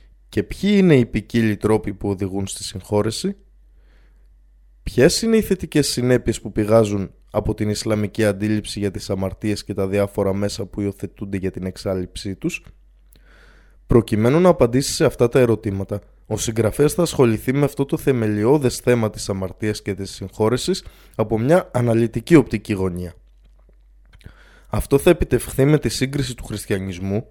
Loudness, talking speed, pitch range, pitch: -20 LUFS, 150 wpm, 100-125 Hz, 110 Hz